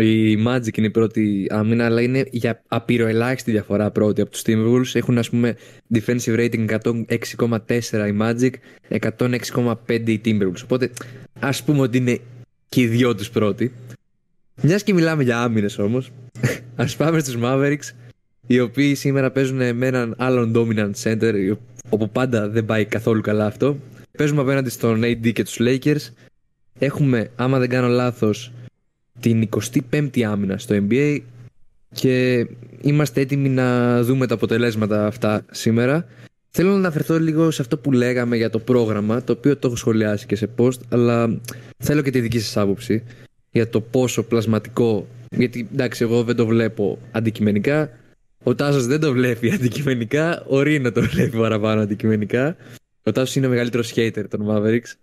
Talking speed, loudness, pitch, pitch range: 160 wpm, -20 LUFS, 120 Hz, 110-130 Hz